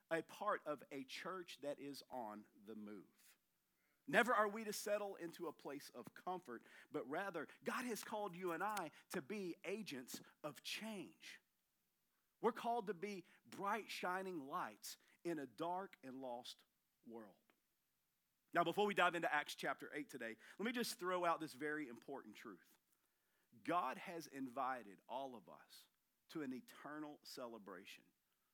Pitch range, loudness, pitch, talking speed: 140-200 Hz, -46 LUFS, 170 Hz, 155 wpm